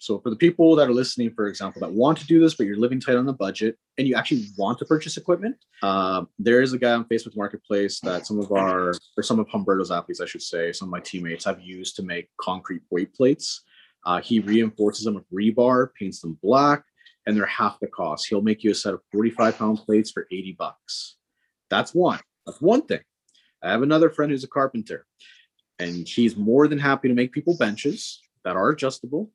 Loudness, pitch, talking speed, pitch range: -23 LUFS, 120 Hz, 225 wpm, 105-150 Hz